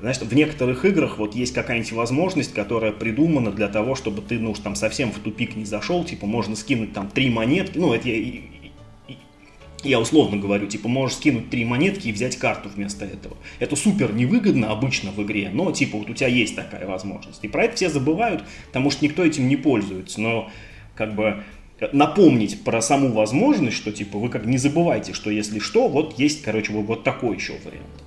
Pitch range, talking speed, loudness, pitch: 105-135 Hz, 200 wpm, -22 LUFS, 115 Hz